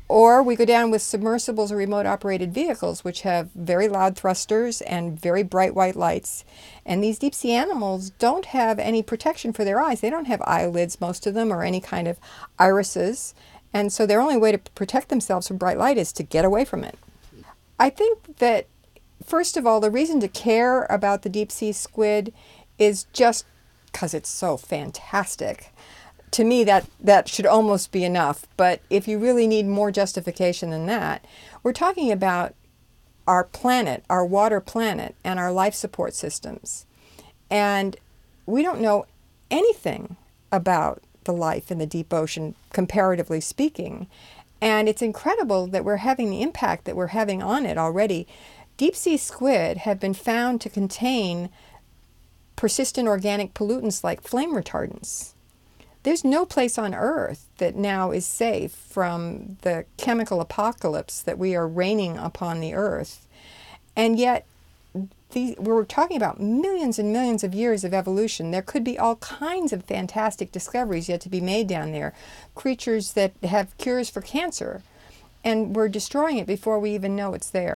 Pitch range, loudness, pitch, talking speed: 185-235 Hz, -23 LUFS, 210 Hz, 165 wpm